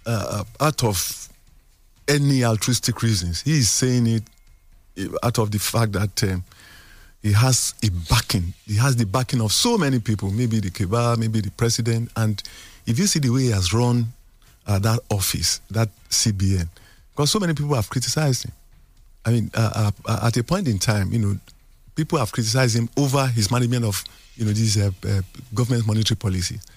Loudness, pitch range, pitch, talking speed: -21 LUFS, 100-125 Hz, 115 Hz, 185 wpm